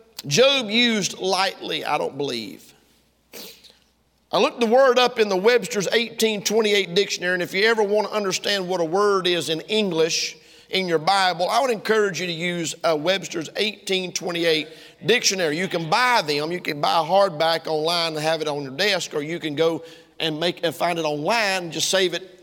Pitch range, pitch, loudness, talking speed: 165-205 Hz, 185 Hz, -21 LUFS, 195 wpm